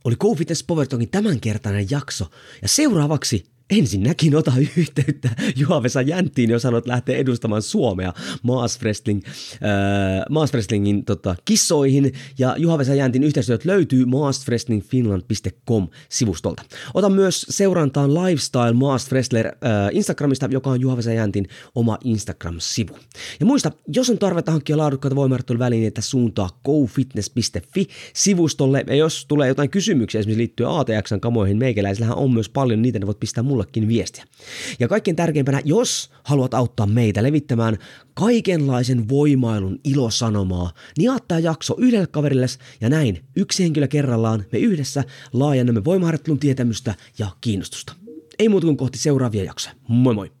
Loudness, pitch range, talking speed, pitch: -20 LUFS, 110-150 Hz, 135 wpm, 130 Hz